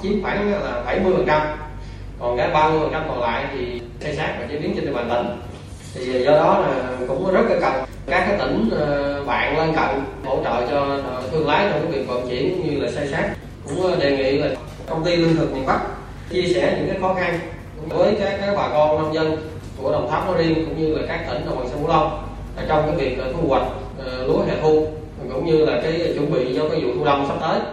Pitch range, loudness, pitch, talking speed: 140-180 Hz, -21 LUFS, 155 Hz, 230 wpm